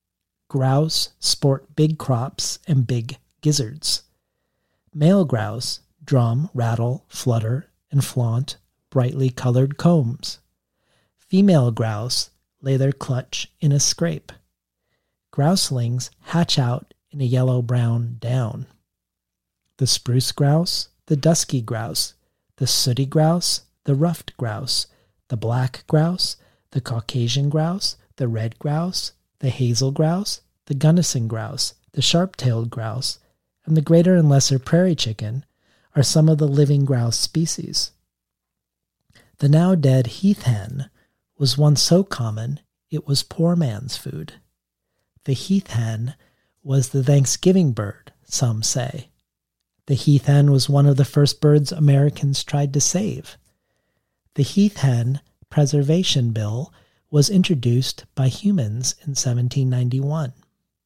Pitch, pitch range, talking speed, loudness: 135 Hz, 120-155 Hz, 125 wpm, -20 LUFS